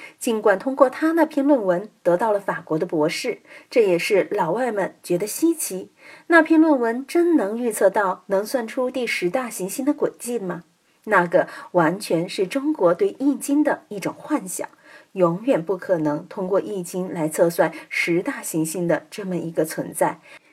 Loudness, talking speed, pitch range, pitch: -22 LUFS, 250 characters per minute, 180-285 Hz, 215 Hz